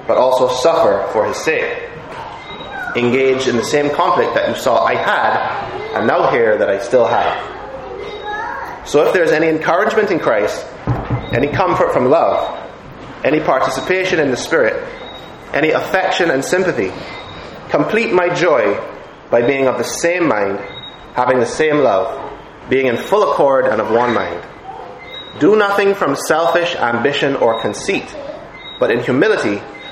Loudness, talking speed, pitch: -15 LUFS, 150 wpm, 175 Hz